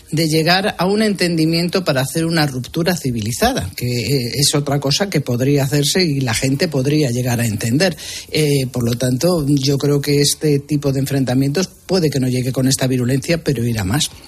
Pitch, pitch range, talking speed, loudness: 145 Hz, 130-160 Hz, 190 wpm, -17 LUFS